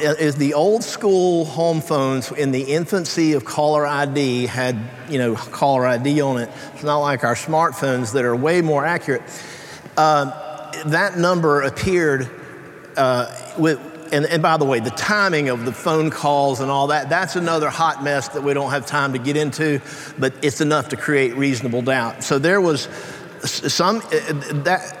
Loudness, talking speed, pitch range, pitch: -19 LUFS, 180 wpm, 135-160 Hz, 145 Hz